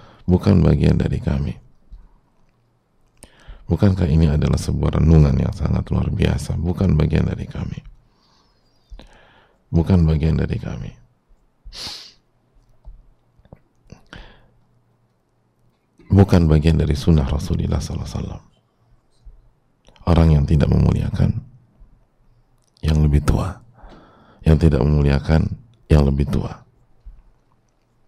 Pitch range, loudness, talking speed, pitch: 75-105 Hz, -18 LUFS, 90 wpm, 85 Hz